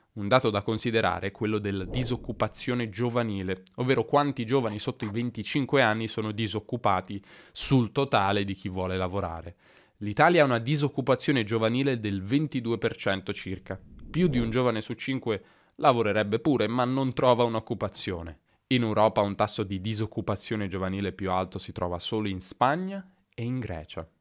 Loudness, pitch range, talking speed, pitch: -27 LUFS, 100-125 Hz, 150 wpm, 110 Hz